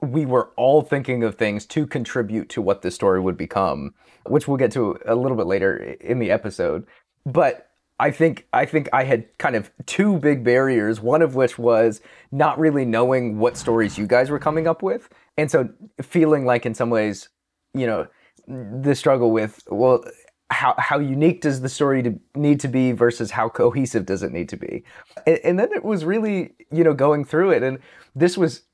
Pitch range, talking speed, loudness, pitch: 115-155 Hz, 200 wpm, -20 LUFS, 135 Hz